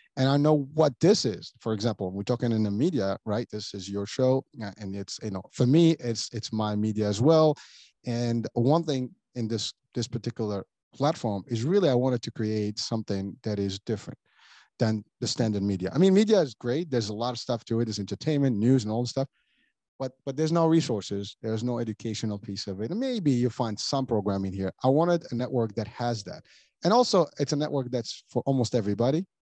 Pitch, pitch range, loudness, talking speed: 120 Hz, 105-135 Hz, -27 LUFS, 215 wpm